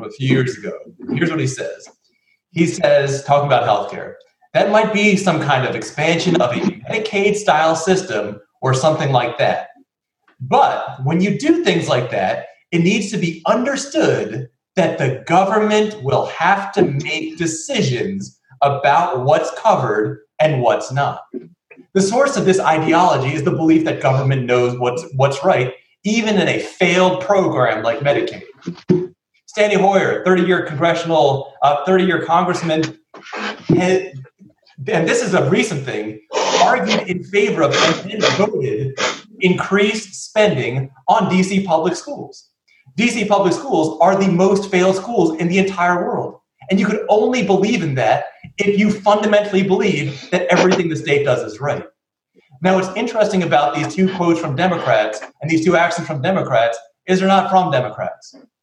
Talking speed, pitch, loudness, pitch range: 155 wpm, 180 Hz, -16 LUFS, 150-200 Hz